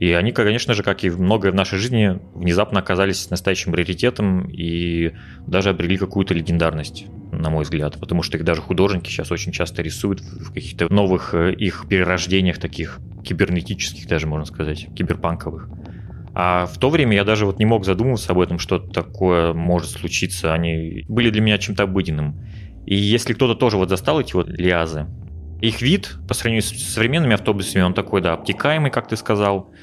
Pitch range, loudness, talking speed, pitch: 85-105 Hz, -20 LUFS, 175 wpm, 95 Hz